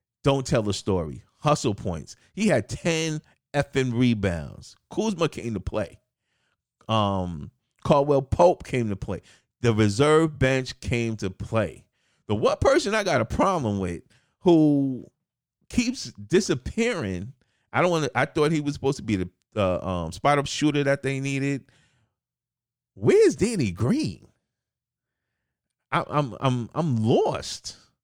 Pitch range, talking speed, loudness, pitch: 105-145 Hz, 140 wpm, -24 LUFS, 125 Hz